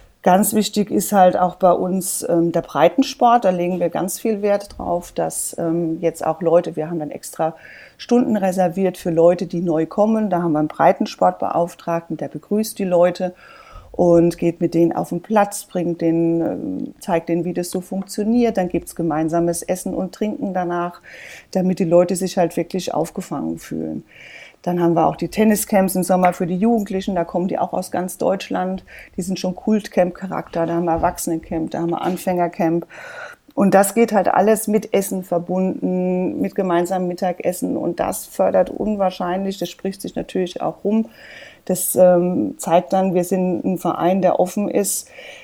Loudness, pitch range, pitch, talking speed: -19 LUFS, 170-195 Hz, 180 Hz, 180 wpm